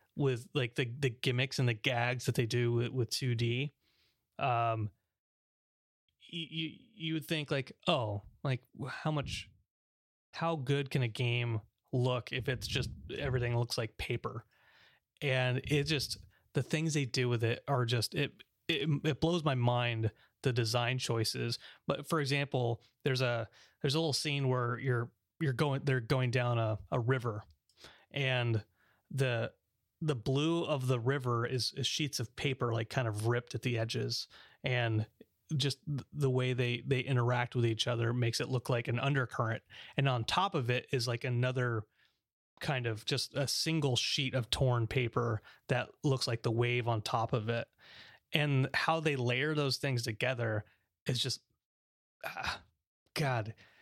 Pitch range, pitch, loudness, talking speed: 115-140 Hz, 125 Hz, -34 LUFS, 165 wpm